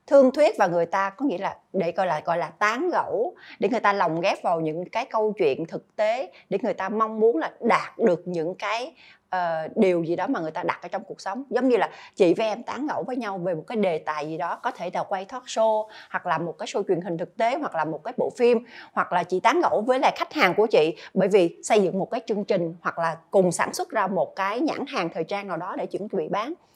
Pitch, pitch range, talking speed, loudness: 210 Hz, 175-245 Hz, 280 wpm, -25 LUFS